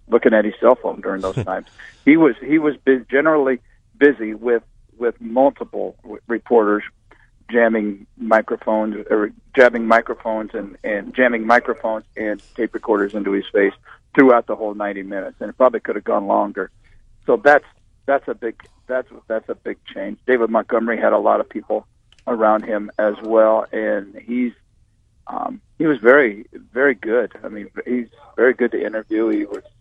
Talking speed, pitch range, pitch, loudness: 170 wpm, 105-120 Hz, 110 Hz, -18 LUFS